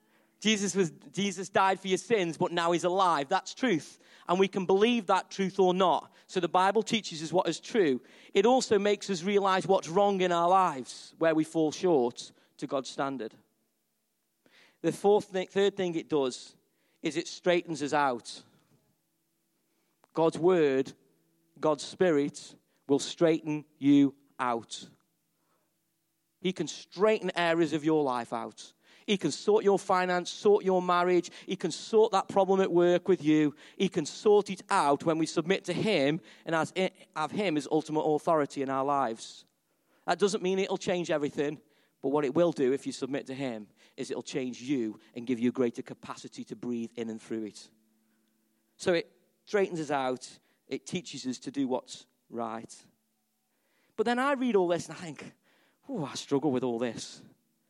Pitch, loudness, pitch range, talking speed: 170 Hz, -29 LUFS, 145-190 Hz, 175 wpm